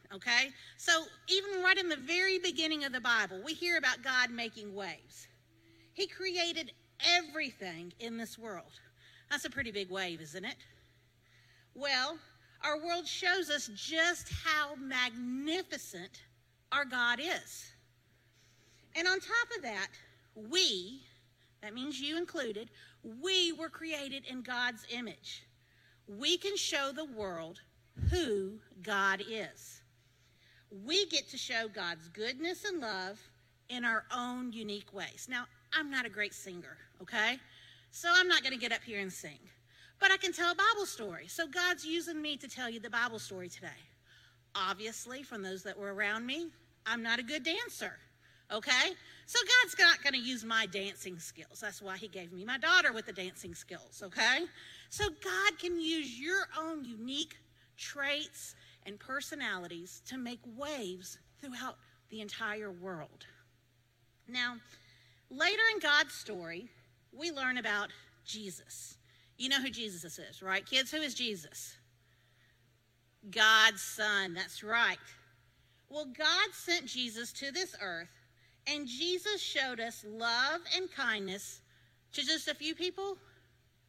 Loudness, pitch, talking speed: -33 LUFS, 230 Hz, 145 wpm